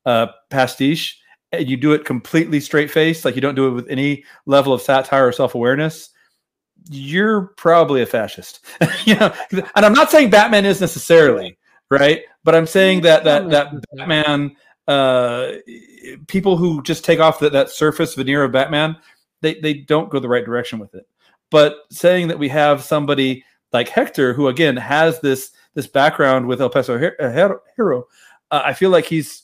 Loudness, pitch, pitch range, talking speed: -16 LUFS, 150 Hz, 135-165 Hz, 185 wpm